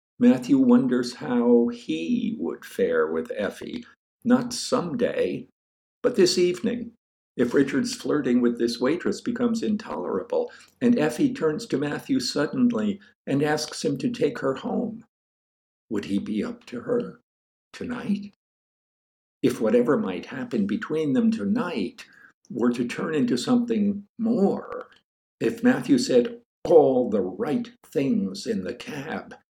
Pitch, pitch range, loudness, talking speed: 235 Hz, 205-250 Hz, -24 LUFS, 130 wpm